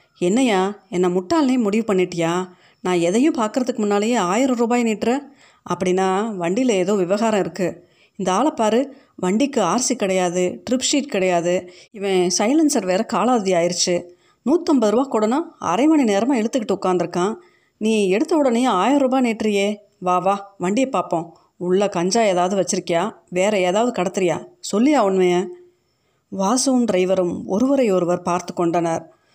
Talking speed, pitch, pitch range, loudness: 130 wpm, 200 Hz, 180-245 Hz, -19 LUFS